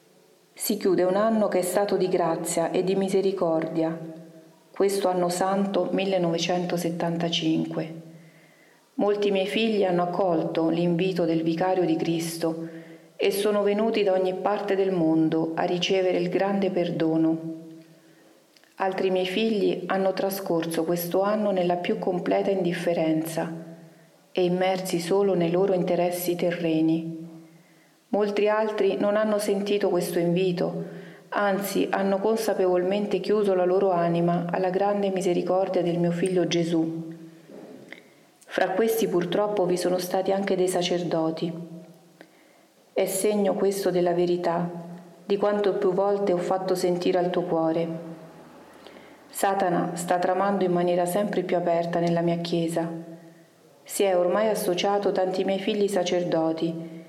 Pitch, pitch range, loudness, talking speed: 180 Hz, 170-195 Hz, -25 LUFS, 125 wpm